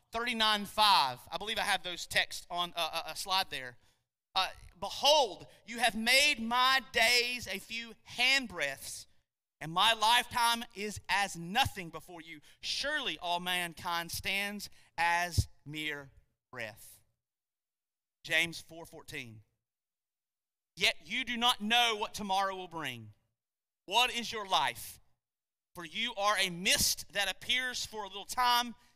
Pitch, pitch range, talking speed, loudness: 190 Hz, 155-230 Hz, 135 wpm, -30 LUFS